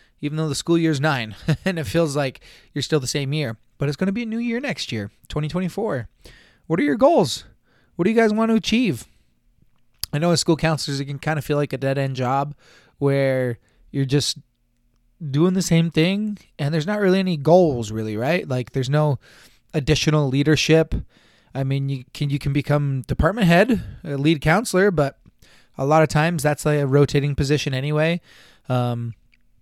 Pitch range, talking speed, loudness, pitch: 135-165 Hz, 195 wpm, -21 LUFS, 150 Hz